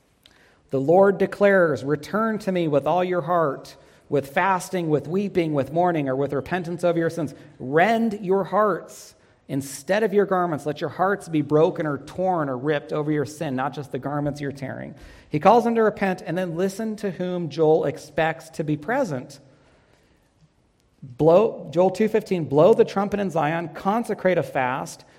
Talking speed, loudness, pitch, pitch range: 175 wpm, -22 LUFS, 165 Hz, 145-190 Hz